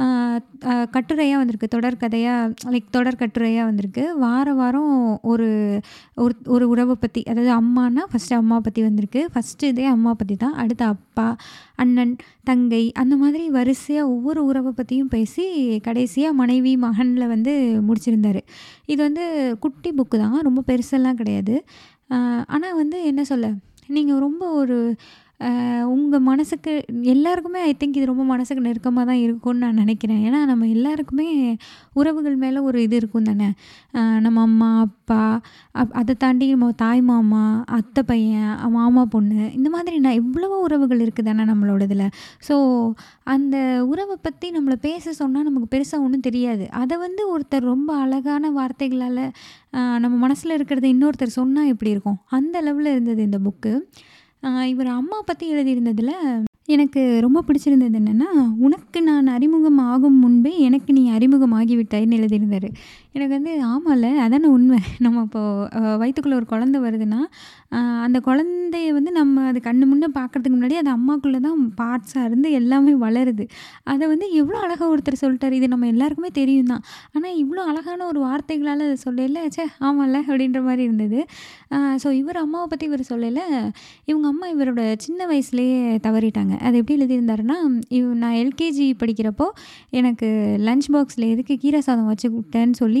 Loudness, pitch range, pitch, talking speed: -19 LUFS, 235-285 Hz, 255 Hz, 145 wpm